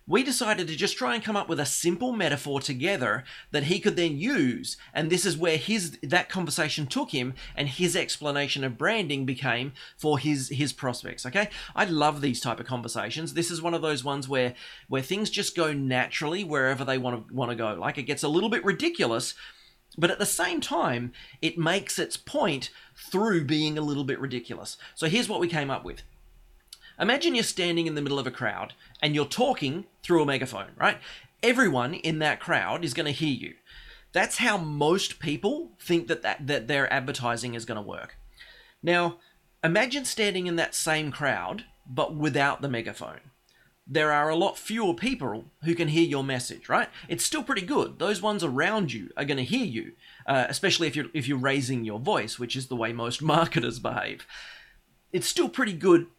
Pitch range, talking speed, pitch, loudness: 135-180 Hz, 200 wpm, 155 Hz, -27 LUFS